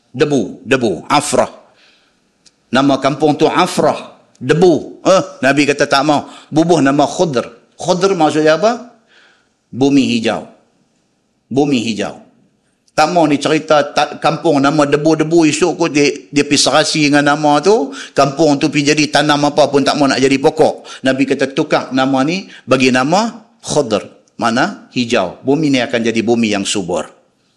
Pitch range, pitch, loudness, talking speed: 135-155 Hz, 145 Hz, -13 LUFS, 150 wpm